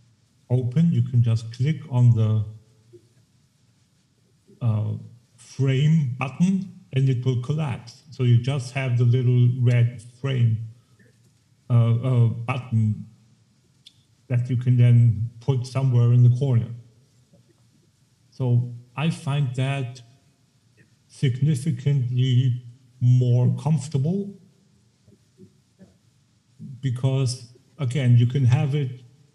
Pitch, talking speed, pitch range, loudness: 125 Hz, 95 wpm, 120-135 Hz, -22 LUFS